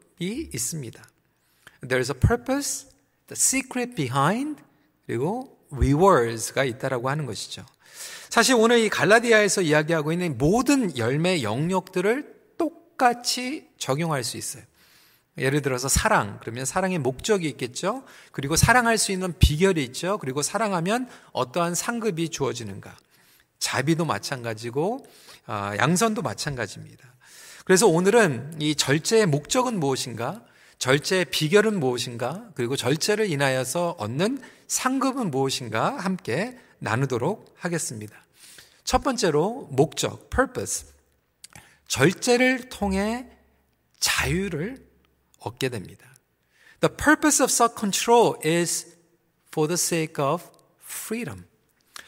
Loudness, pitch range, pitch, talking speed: -24 LUFS, 130-225 Hz, 170 Hz, 330 characters per minute